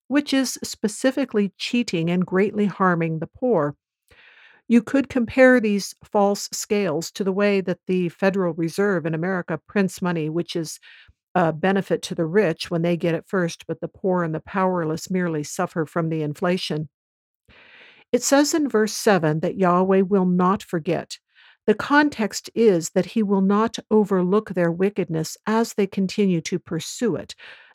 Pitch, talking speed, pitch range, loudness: 190 Hz, 160 wpm, 170-215 Hz, -22 LUFS